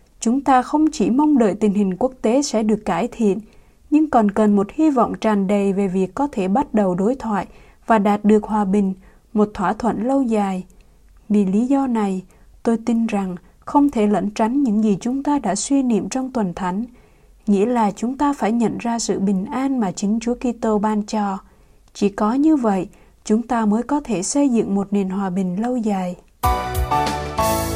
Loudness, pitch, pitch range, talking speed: -19 LUFS, 215 Hz, 200-240 Hz, 205 wpm